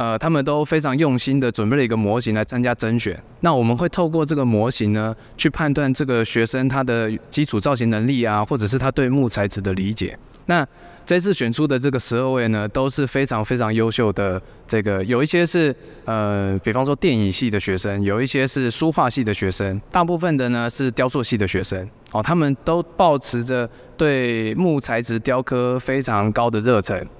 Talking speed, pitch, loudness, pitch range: 300 characters per minute, 125 Hz, -20 LUFS, 110-140 Hz